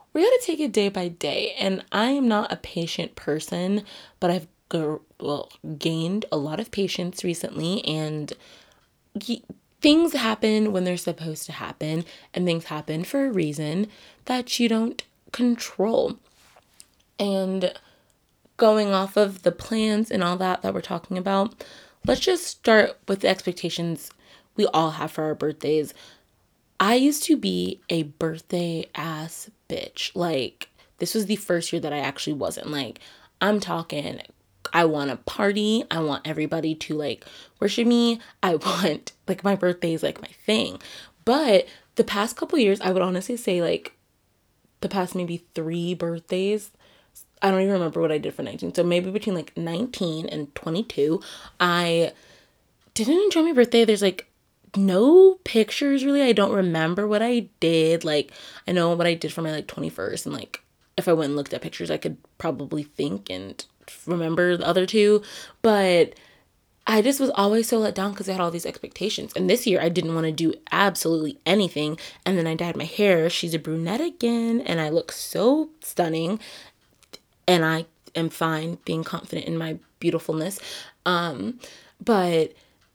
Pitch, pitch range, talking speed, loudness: 180 Hz, 165-215 Hz, 170 wpm, -24 LUFS